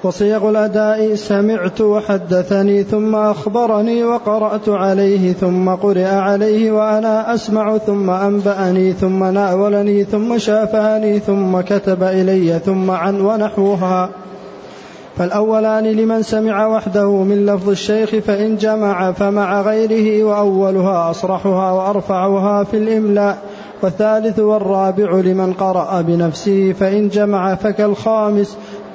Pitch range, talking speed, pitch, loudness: 190-215 Hz, 100 wpm, 205 Hz, -15 LUFS